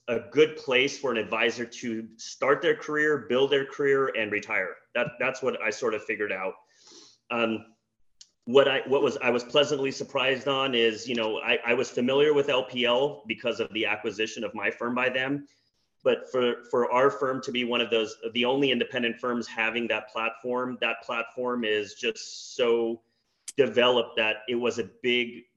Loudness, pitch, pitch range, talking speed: -26 LUFS, 120 Hz, 115-135 Hz, 180 wpm